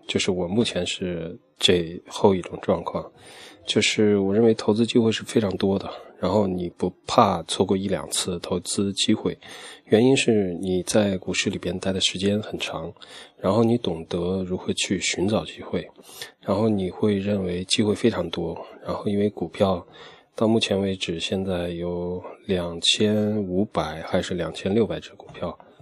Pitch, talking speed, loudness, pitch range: 100 Hz, 245 characters per minute, -24 LUFS, 90-105 Hz